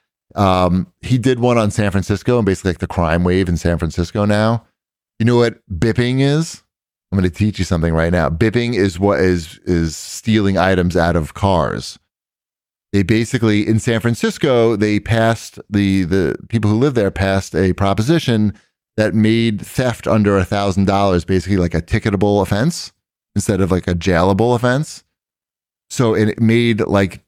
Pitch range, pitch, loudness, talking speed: 95-115 Hz, 100 Hz, -16 LUFS, 170 wpm